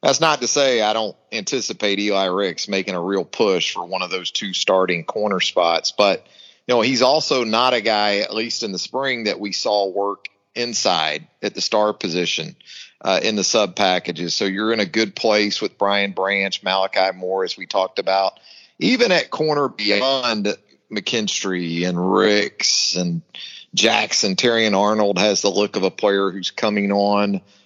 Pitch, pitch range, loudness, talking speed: 100 Hz, 95-105 Hz, -19 LUFS, 180 wpm